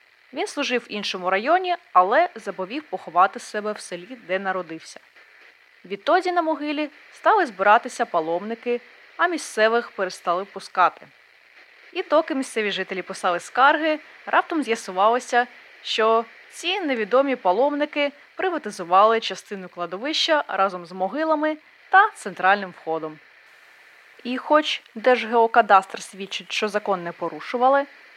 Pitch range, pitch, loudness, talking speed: 190-295 Hz, 230 Hz, -22 LUFS, 110 wpm